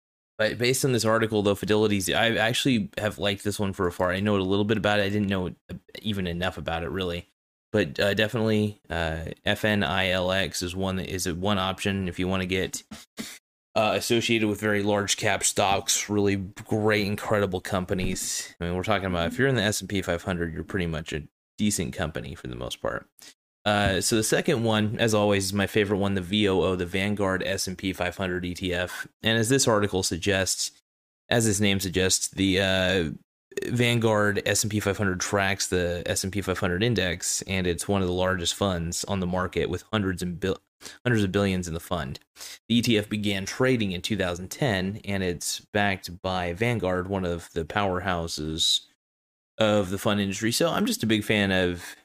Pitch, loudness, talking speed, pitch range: 95 Hz, -25 LUFS, 195 wpm, 90-105 Hz